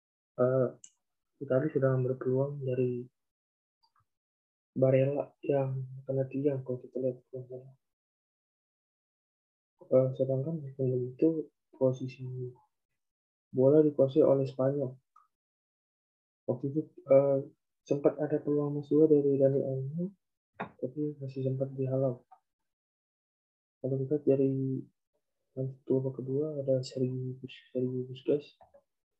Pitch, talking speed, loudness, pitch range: 130 Hz, 90 wpm, -31 LUFS, 125-140 Hz